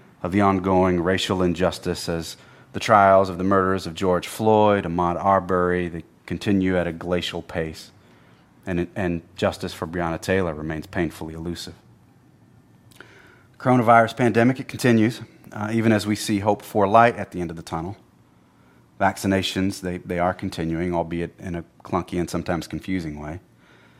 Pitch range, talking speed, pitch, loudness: 85-100 Hz, 155 wpm, 90 Hz, -22 LUFS